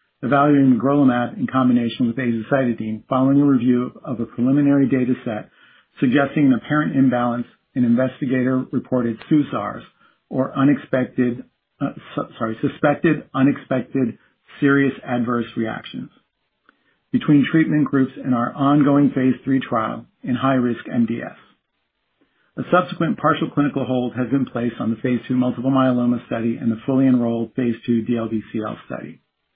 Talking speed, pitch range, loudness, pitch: 140 wpm, 120-140 Hz, -20 LUFS, 130 Hz